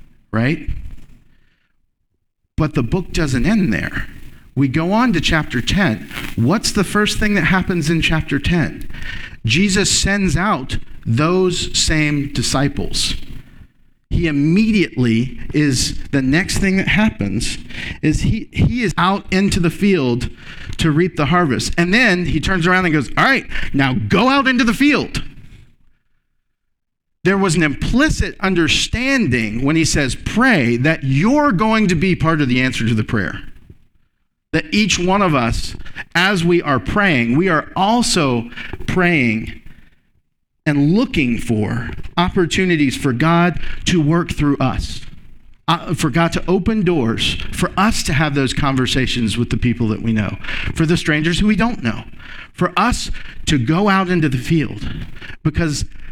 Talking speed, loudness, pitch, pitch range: 150 wpm, -16 LUFS, 155 Hz, 120-185 Hz